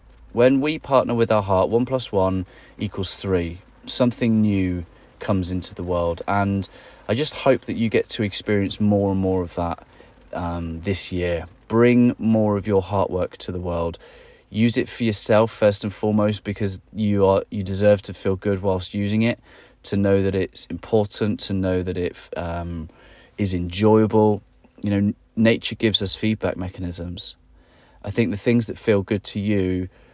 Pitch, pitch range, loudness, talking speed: 100 Hz, 90-110 Hz, -21 LUFS, 175 wpm